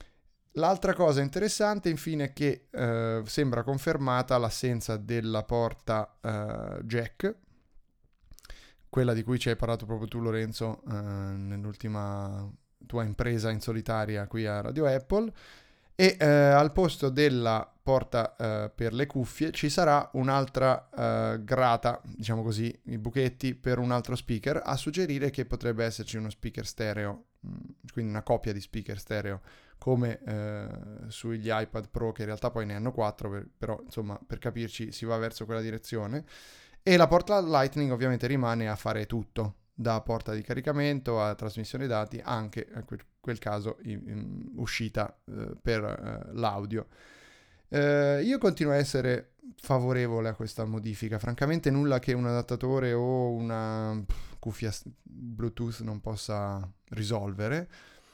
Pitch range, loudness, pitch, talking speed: 110-130 Hz, -30 LUFS, 115 Hz, 145 wpm